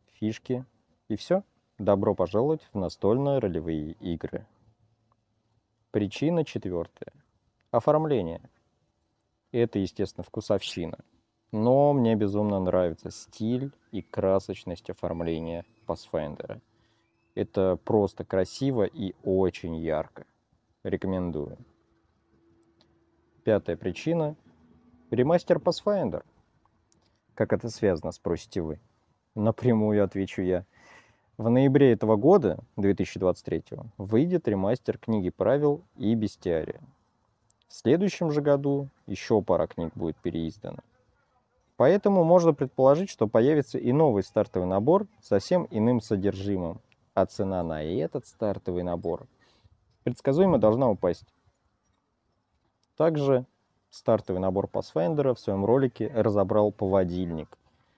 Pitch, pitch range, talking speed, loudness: 110 Hz, 95-125 Hz, 95 wpm, -27 LUFS